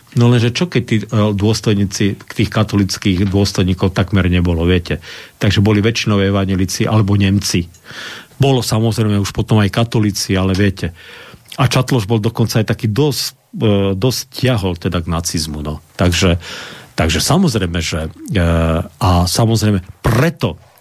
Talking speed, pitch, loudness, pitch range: 135 wpm, 105 Hz, -15 LUFS, 95-115 Hz